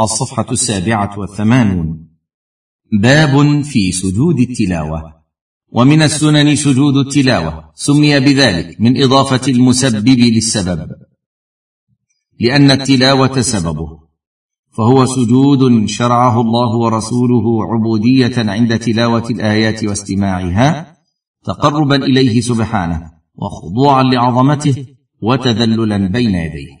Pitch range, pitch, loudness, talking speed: 100-135 Hz, 120 Hz, -12 LUFS, 85 wpm